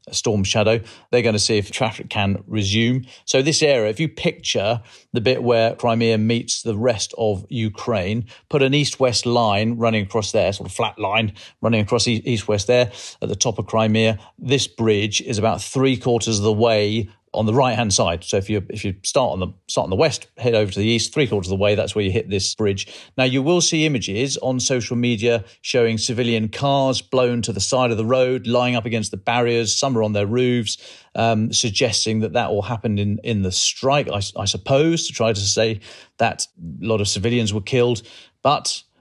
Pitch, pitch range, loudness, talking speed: 115 Hz, 105-125 Hz, -20 LUFS, 220 wpm